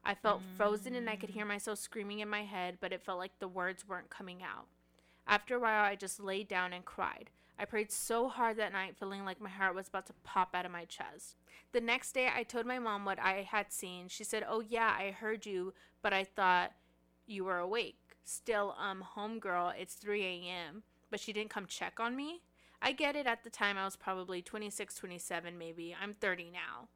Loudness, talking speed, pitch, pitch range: -38 LUFS, 225 wpm, 200 Hz, 185-215 Hz